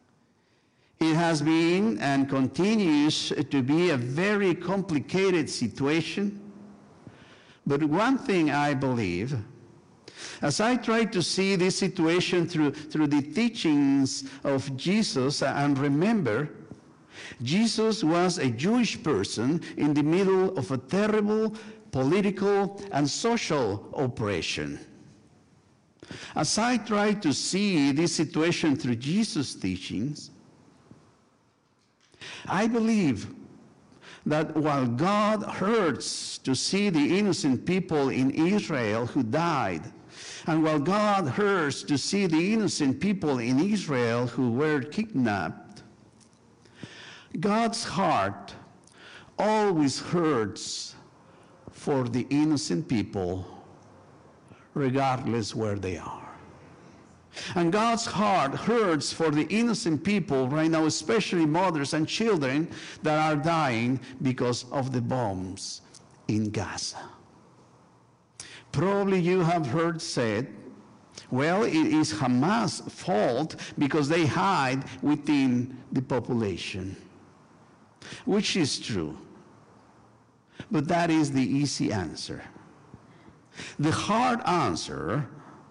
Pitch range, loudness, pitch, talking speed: 130-190 Hz, -26 LUFS, 155 Hz, 105 wpm